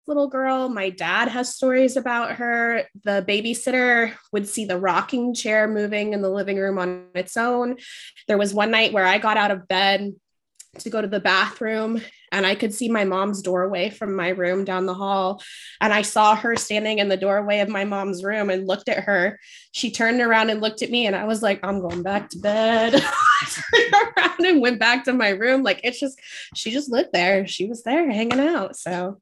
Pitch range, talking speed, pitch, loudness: 195-245 Hz, 215 wpm, 215 Hz, -21 LUFS